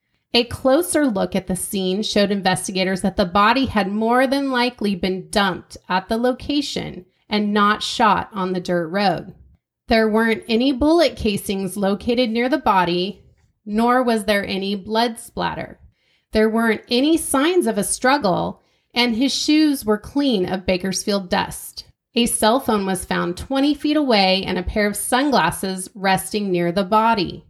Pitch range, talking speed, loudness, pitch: 190-250 Hz, 160 wpm, -19 LUFS, 215 Hz